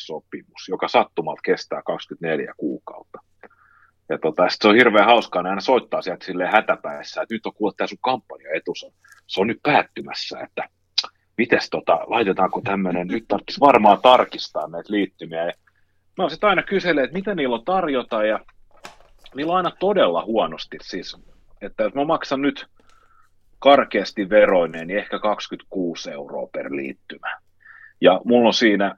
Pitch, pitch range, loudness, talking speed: 115 Hz, 95-160 Hz, -20 LUFS, 150 wpm